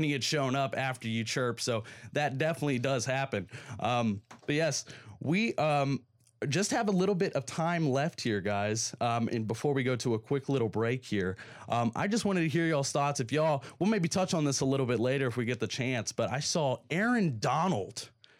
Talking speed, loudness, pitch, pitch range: 220 wpm, -31 LUFS, 135 Hz, 120-150 Hz